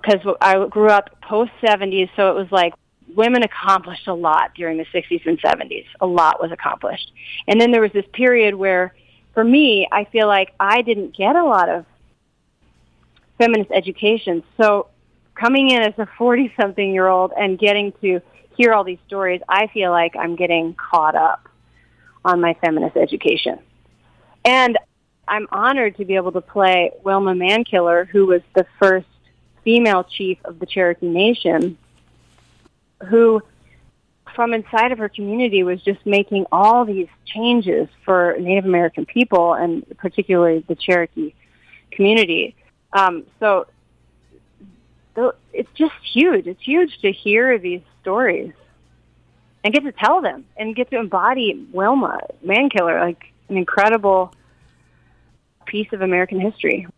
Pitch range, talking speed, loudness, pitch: 180-225 Hz, 145 wpm, -17 LUFS, 200 Hz